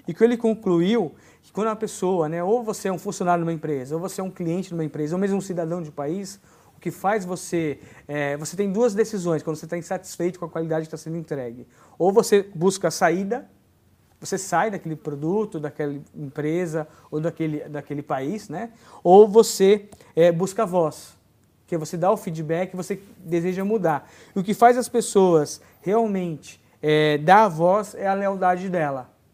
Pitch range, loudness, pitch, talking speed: 155-195 Hz, -23 LUFS, 175 Hz, 200 wpm